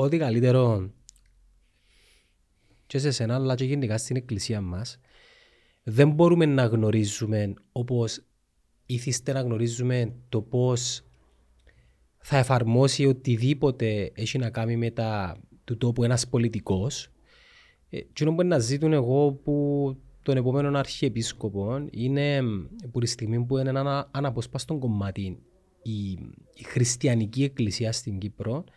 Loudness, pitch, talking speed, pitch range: -26 LUFS, 120 Hz, 120 wpm, 110-135 Hz